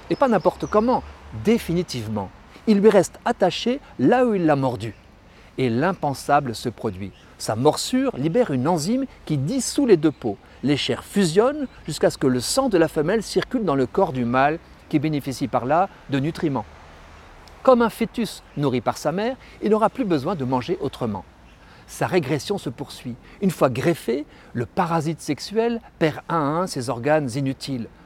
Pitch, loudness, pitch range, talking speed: 150 Hz, -22 LUFS, 125-200 Hz, 175 wpm